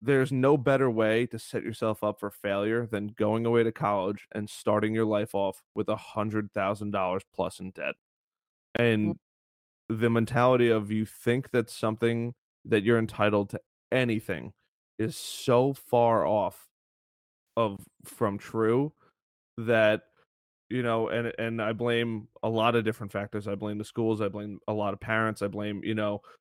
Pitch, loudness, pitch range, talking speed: 110 Hz, -28 LUFS, 105-115 Hz, 170 wpm